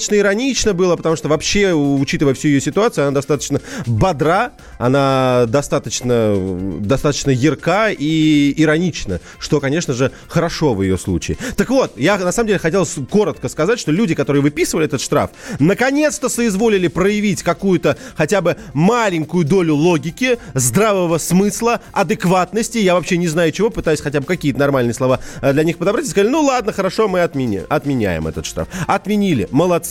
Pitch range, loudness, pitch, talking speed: 140-200 Hz, -16 LUFS, 165 Hz, 160 wpm